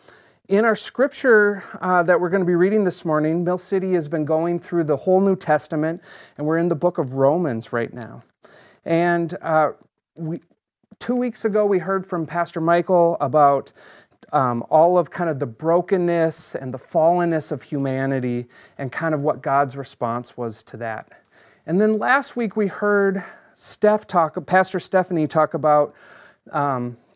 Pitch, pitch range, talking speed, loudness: 170 Hz, 150-185 Hz, 170 wpm, -21 LUFS